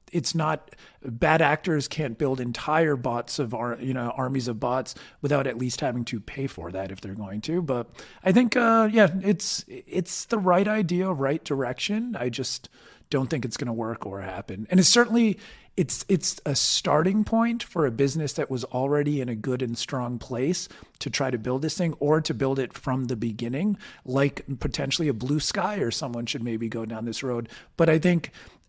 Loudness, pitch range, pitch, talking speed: -26 LUFS, 120-170 Hz, 140 Hz, 205 wpm